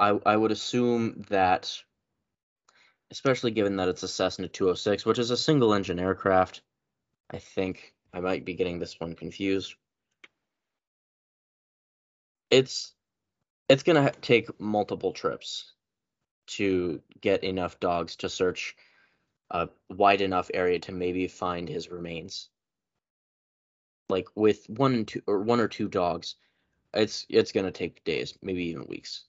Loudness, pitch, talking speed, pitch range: -27 LUFS, 95 Hz, 140 wpm, 90-110 Hz